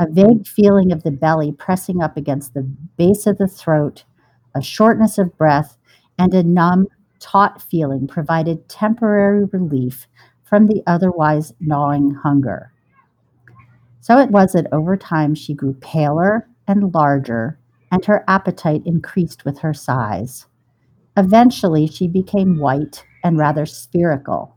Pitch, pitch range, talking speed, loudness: 160 Hz, 140-190 Hz, 135 wpm, -16 LUFS